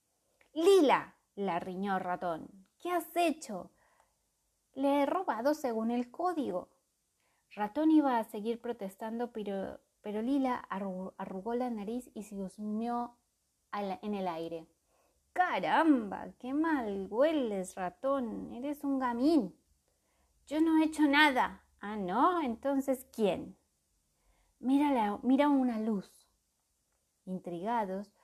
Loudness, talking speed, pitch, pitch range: -32 LUFS, 115 wpm, 235 Hz, 195-280 Hz